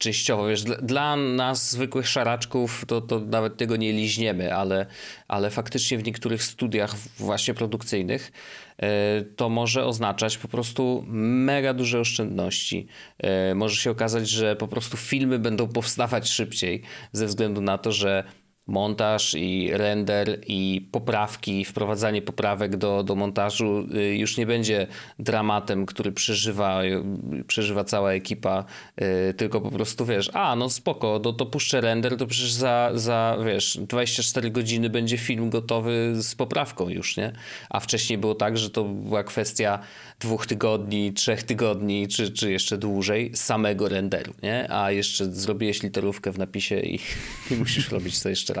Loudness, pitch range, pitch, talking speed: -25 LUFS, 100-120 Hz, 110 Hz, 145 wpm